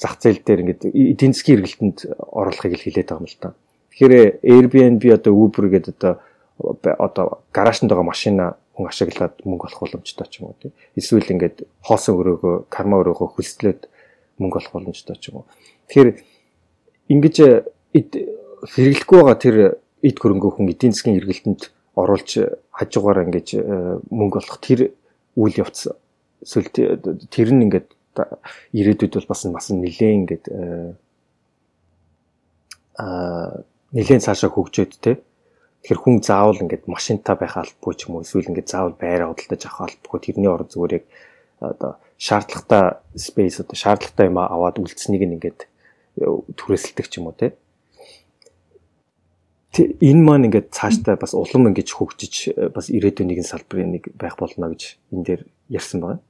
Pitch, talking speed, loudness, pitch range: 100 Hz, 145 wpm, -17 LUFS, 85-125 Hz